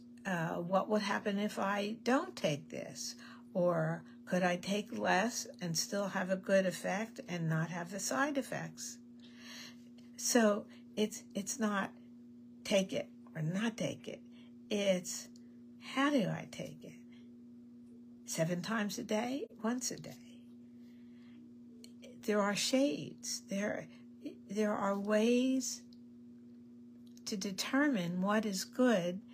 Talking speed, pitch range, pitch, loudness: 125 wpm, 195-240 Hz, 235 Hz, -35 LUFS